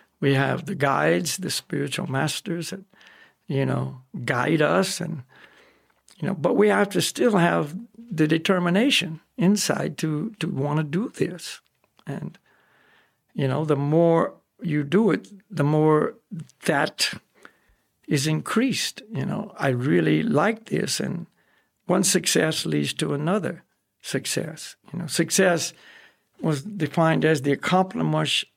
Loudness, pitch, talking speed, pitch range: -23 LUFS, 165 Hz, 135 wpm, 150-190 Hz